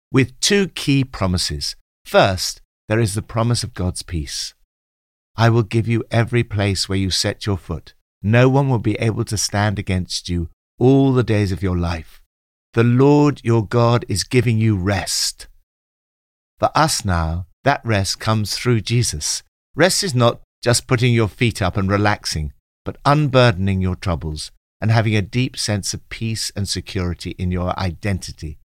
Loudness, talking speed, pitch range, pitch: -19 LUFS, 165 wpm, 90-115 Hz, 100 Hz